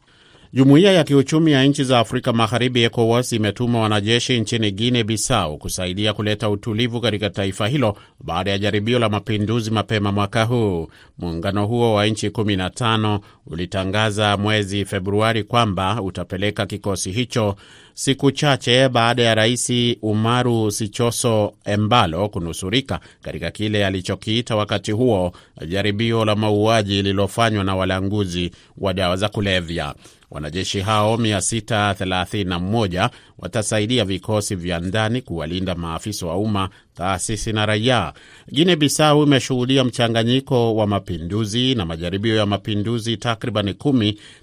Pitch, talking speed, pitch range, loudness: 105 Hz, 120 wpm, 100-120 Hz, -19 LUFS